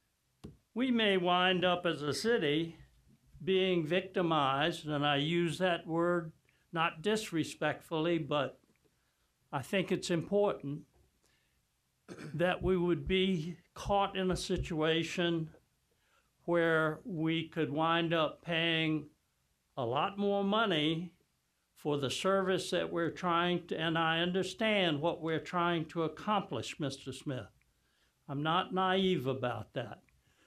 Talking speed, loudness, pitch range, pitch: 120 wpm, -33 LUFS, 150-185 Hz, 165 Hz